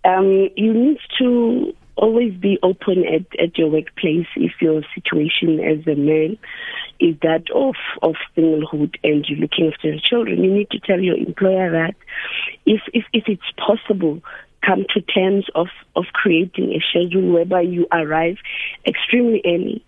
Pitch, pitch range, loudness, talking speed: 185 Hz, 160-215 Hz, -18 LUFS, 160 wpm